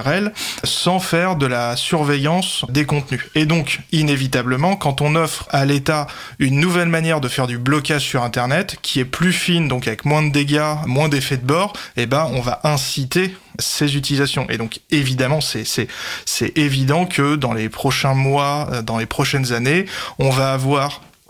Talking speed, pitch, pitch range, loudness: 180 wpm, 145 Hz, 135-155 Hz, -18 LUFS